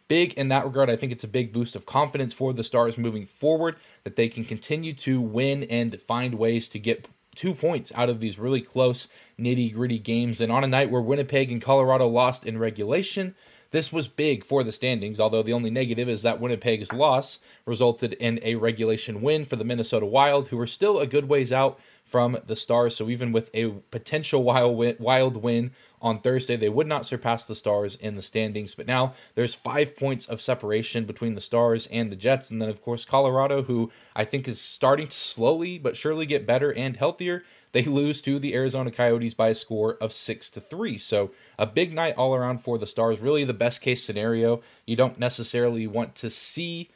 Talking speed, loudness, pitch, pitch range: 210 wpm, -25 LUFS, 120 Hz, 115-135 Hz